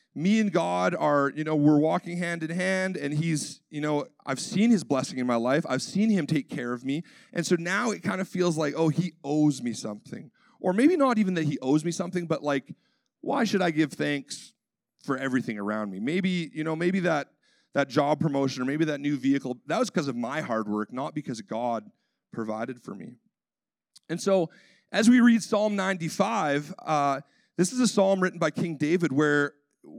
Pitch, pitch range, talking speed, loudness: 160 Hz, 140-185 Hz, 210 wpm, -27 LUFS